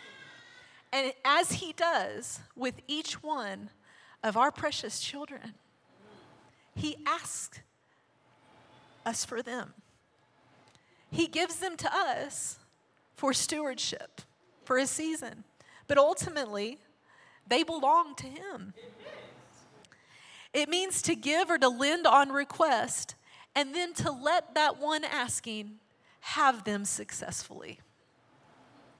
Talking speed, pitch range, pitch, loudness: 105 wpm, 255-330 Hz, 290 Hz, -30 LUFS